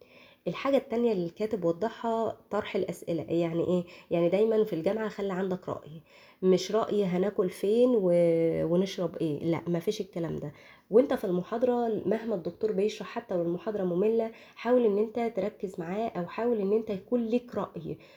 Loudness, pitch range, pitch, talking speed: -29 LUFS, 175-225 Hz, 205 Hz, 160 wpm